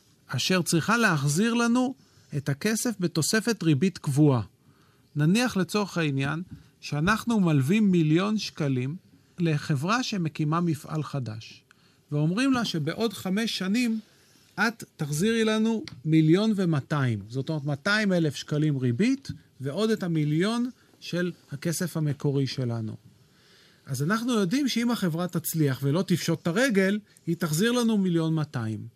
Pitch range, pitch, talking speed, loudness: 145-210 Hz, 170 Hz, 120 wpm, -26 LUFS